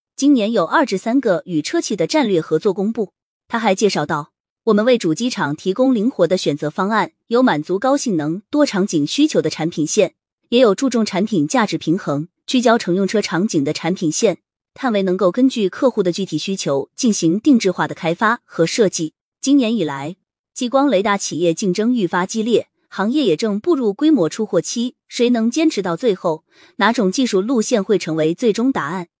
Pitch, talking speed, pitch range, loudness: 205 Hz, 295 characters per minute, 170-250 Hz, -18 LUFS